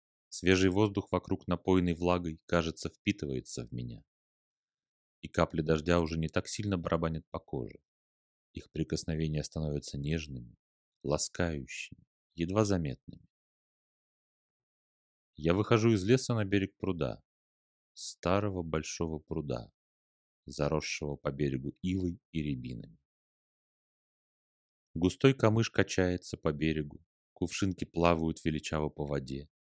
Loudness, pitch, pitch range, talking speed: -33 LUFS, 80 Hz, 70-90 Hz, 105 wpm